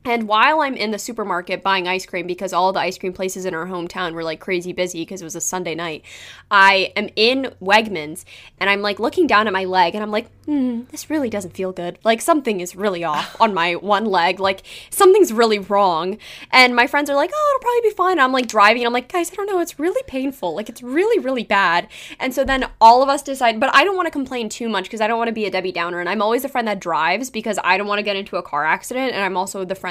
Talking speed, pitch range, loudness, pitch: 275 wpm, 185-260 Hz, -18 LUFS, 210 Hz